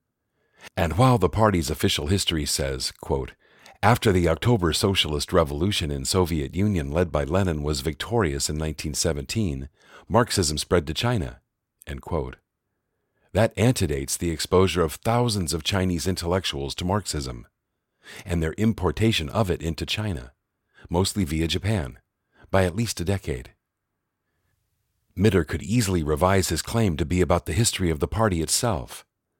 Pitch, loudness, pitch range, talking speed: 90 Hz, -24 LUFS, 80-105 Hz, 145 wpm